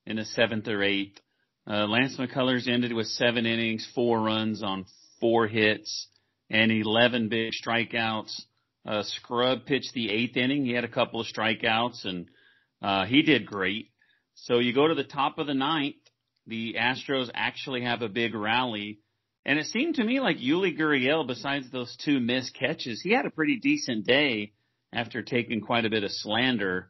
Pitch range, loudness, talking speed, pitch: 110-130 Hz, -27 LUFS, 180 wpm, 120 Hz